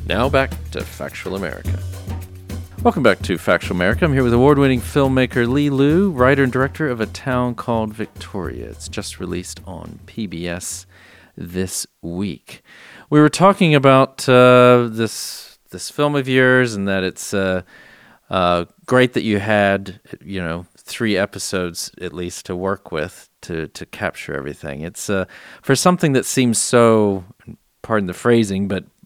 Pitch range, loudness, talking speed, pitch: 90-130 Hz, -18 LUFS, 155 wpm, 105 Hz